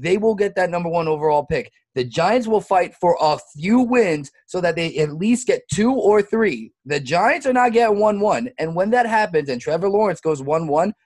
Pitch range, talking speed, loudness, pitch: 155-220 Hz, 230 wpm, -19 LUFS, 180 Hz